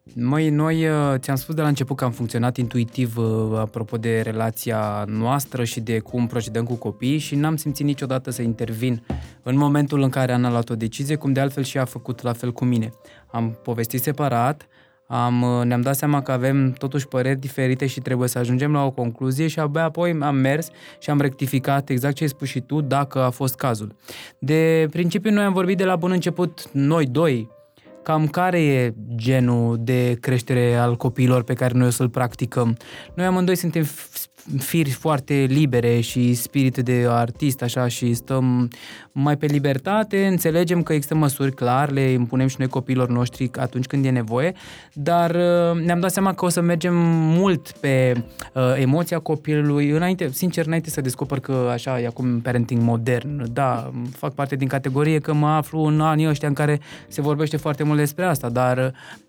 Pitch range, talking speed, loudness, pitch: 125-150 Hz, 185 wpm, -21 LUFS, 135 Hz